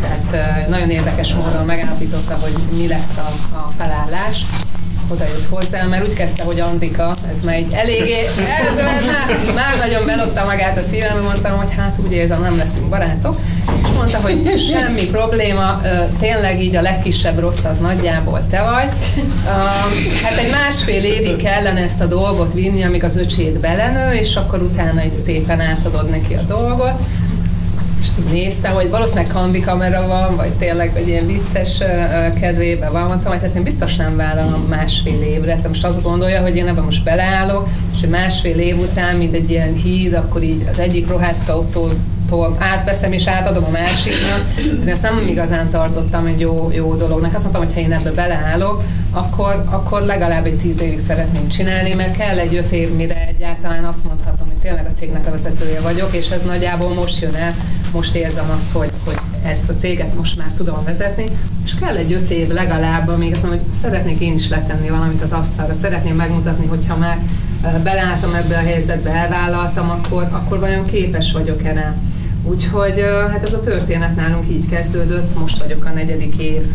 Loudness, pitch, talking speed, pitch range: -16 LUFS, 90 Hz, 175 wpm, 85-95 Hz